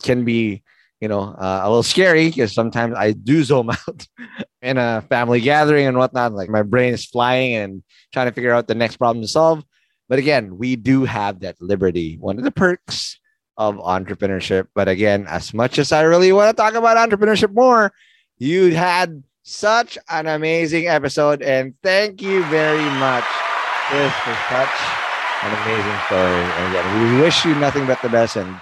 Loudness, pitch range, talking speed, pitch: -17 LUFS, 105-160 Hz, 180 wpm, 125 Hz